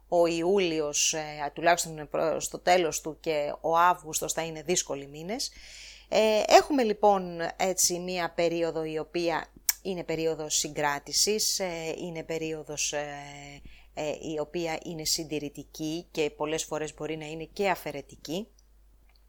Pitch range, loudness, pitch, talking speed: 150-175 Hz, -28 LUFS, 160 Hz, 115 wpm